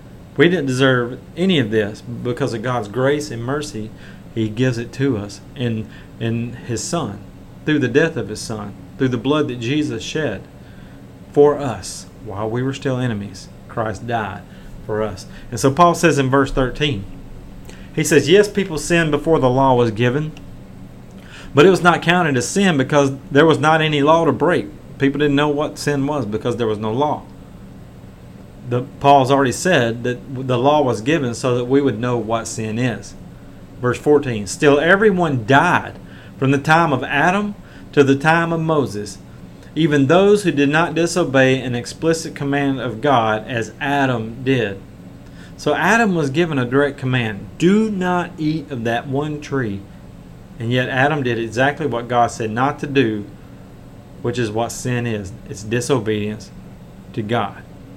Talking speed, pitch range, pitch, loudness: 175 wpm, 115-150 Hz, 135 Hz, -18 LUFS